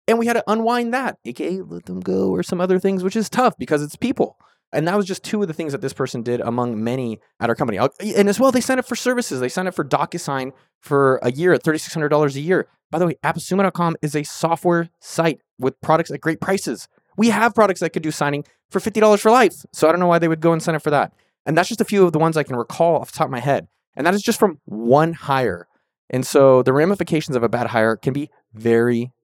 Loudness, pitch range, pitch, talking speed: -19 LUFS, 135-190 Hz, 160 Hz, 265 wpm